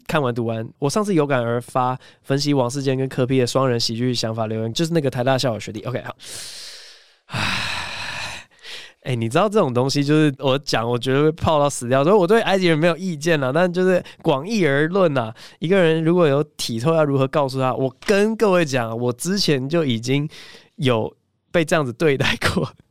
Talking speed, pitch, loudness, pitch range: 300 characters per minute, 140 Hz, -20 LUFS, 125-170 Hz